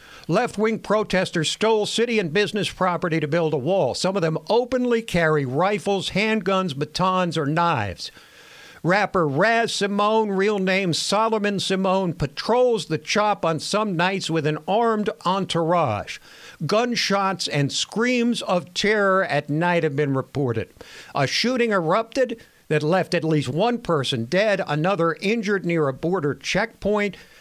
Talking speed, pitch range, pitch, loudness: 140 wpm, 160-210 Hz, 185 Hz, -22 LUFS